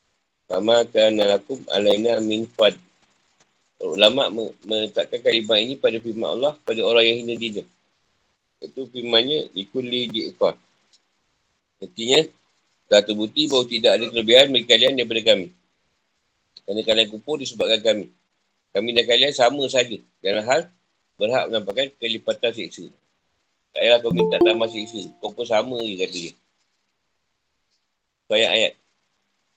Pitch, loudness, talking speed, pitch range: 115 Hz, -20 LUFS, 120 wpm, 105-125 Hz